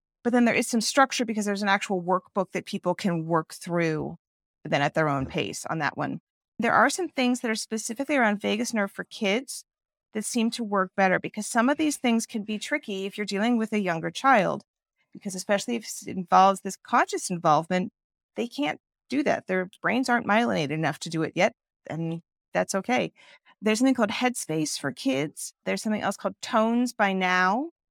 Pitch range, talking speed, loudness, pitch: 185-240 Hz, 200 wpm, -26 LUFS, 210 Hz